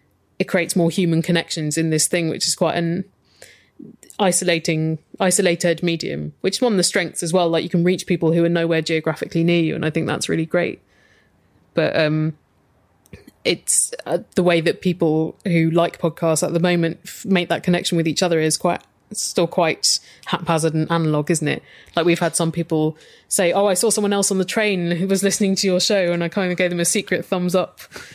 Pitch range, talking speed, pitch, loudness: 165-185 Hz, 215 wpm, 170 Hz, -19 LUFS